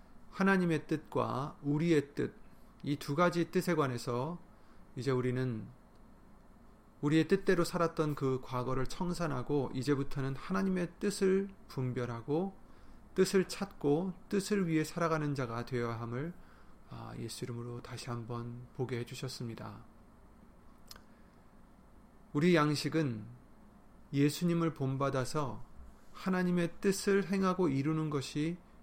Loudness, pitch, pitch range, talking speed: -34 LUFS, 150 Hz, 130-175 Hz, 250 characters per minute